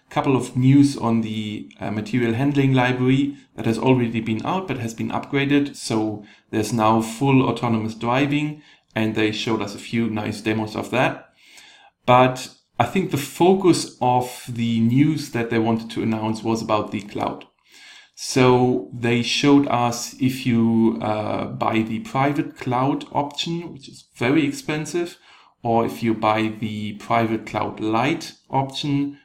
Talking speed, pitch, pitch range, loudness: 155 wpm, 120 Hz, 110-140 Hz, -21 LUFS